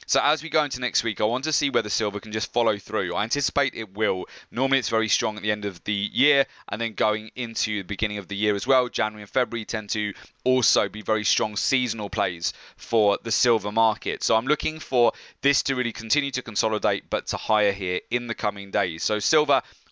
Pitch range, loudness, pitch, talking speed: 105-125 Hz, -24 LUFS, 110 Hz, 230 wpm